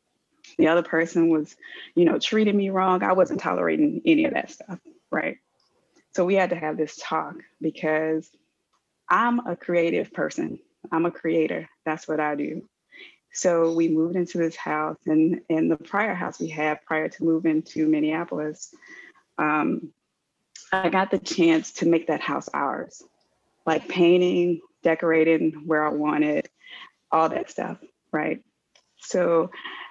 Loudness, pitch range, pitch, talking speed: -24 LUFS, 155-185 Hz, 165 Hz, 150 wpm